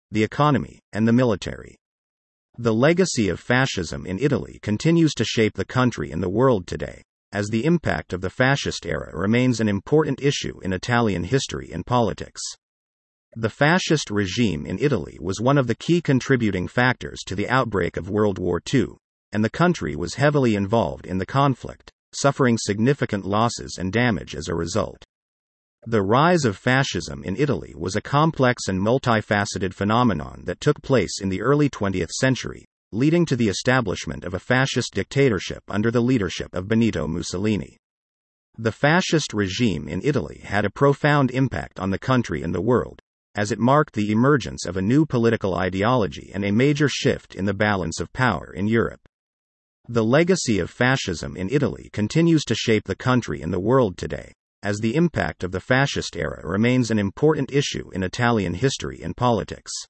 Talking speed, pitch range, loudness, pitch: 175 wpm, 95-130 Hz, -22 LUFS, 110 Hz